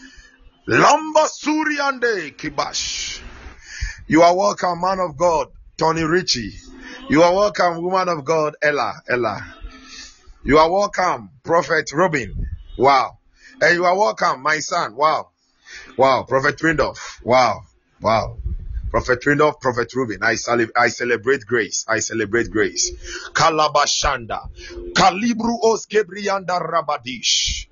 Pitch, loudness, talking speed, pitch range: 165 Hz, -18 LUFS, 115 wpm, 125-195 Hz